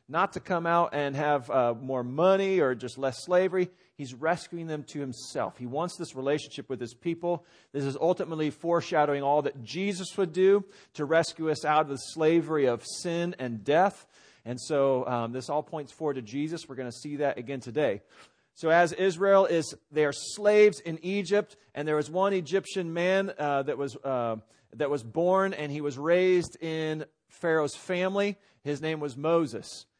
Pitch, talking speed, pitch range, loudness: 155 Hz, 190 wpm, 140-180 Hz, -28 LUFS